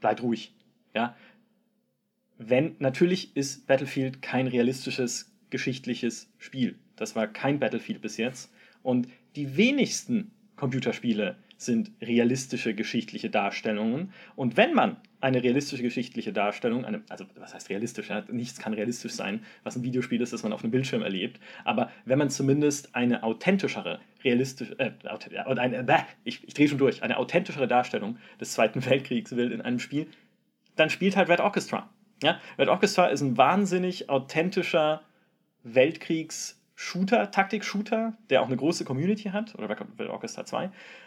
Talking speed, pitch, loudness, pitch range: 145 wpm, 140 Hz, -28 LUFS, 125-195 Hz